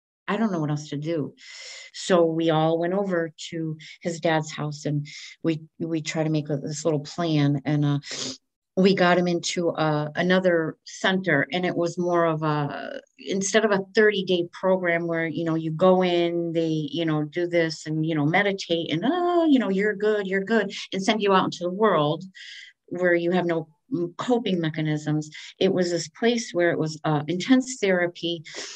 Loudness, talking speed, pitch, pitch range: -24 LUFS, 195 wpm, 170 Hz, 155-190 Hz